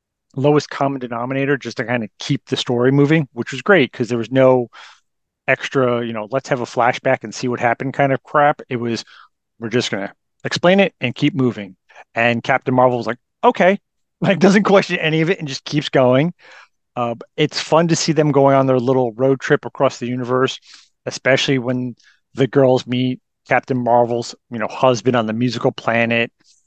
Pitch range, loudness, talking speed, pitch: 120-145 Hz, -17 LUFS, 195 wpm, 130 Hz